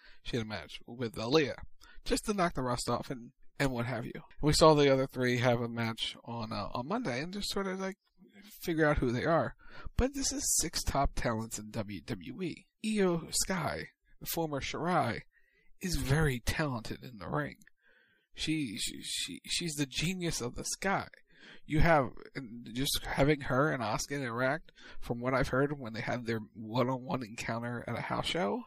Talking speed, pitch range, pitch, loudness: 195 wpm, 120-165 Hz, 135 Hz, -33 LUFS